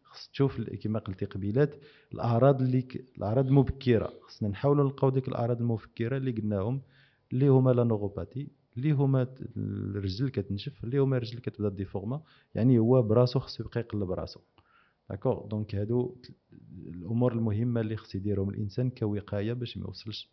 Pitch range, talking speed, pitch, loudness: 105-130 Hz, 155 wpm, 115 Hz, -29 LUFS